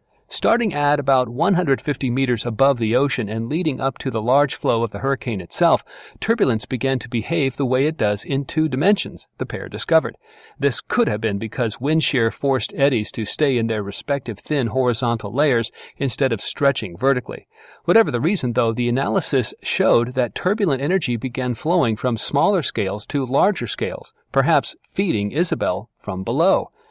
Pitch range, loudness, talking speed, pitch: 115-140 Hz, -21 LUFS, 170 wpm, 130 Hz